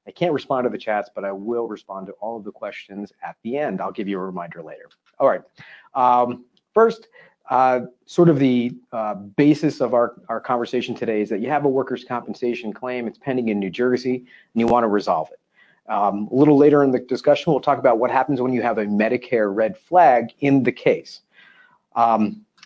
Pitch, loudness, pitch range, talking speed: 125 Hz, -20 LUFS, 110-135 Hz, 215 wpm